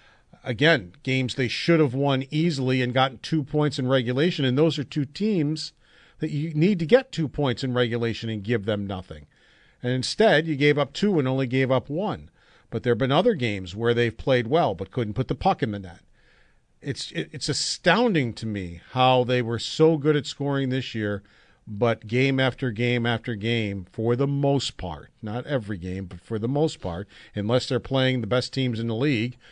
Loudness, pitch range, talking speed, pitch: -24 LUFS, 115-145 Hz, 205 wpm, 130 Hz